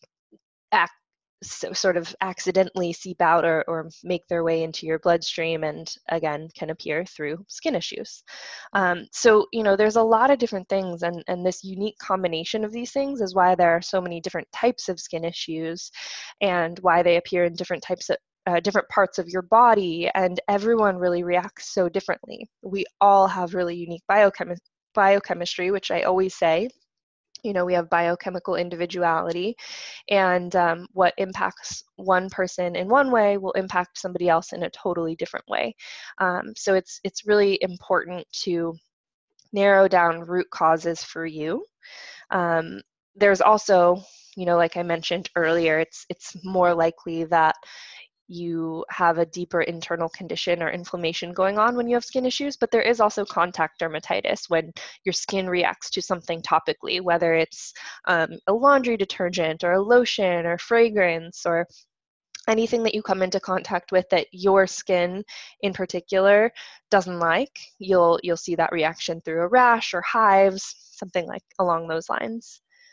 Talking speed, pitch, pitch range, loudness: 165 wpm, 180 Hz, 170-200 Hz, -23 LUFS